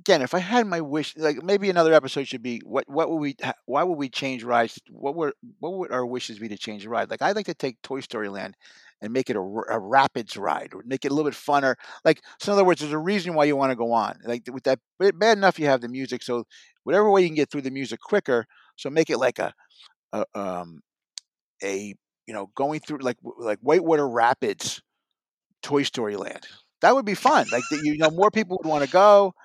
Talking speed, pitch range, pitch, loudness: 245 wpm, 125-175 Hz, 145 Hz, -24 LUFS